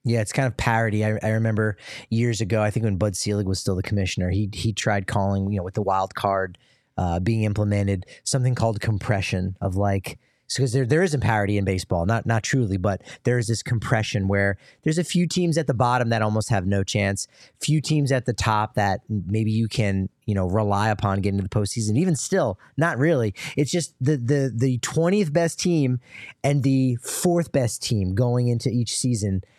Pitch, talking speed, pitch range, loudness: 110 Hz, 215 wpm, 100-130 Hz, -23 LUFS